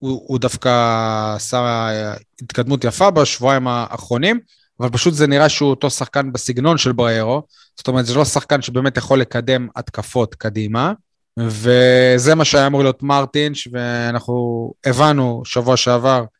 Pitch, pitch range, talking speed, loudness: 125 Hz, 120-140 Hz, 140 wpm, -16 LUFS